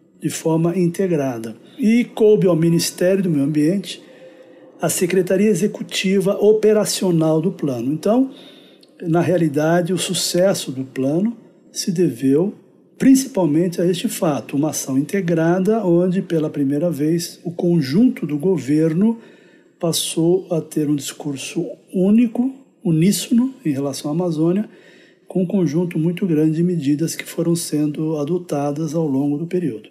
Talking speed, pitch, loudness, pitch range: 130 wpm, 175 Hz, -19 LUFS, 155-190 Hz